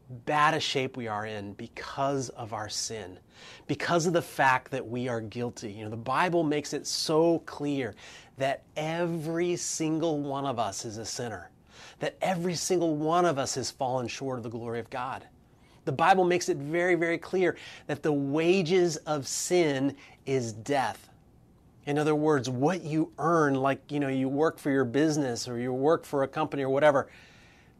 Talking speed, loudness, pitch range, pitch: 185 wpm, -28 LUFS, 125-160 Hz, 140 Hz